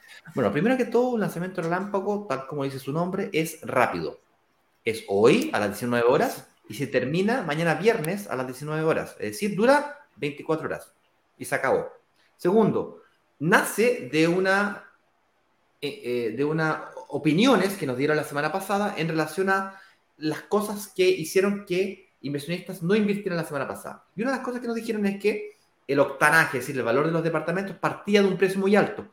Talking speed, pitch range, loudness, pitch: 185 wpm, 150-205 Hz, -25 LUFS, 180 Hz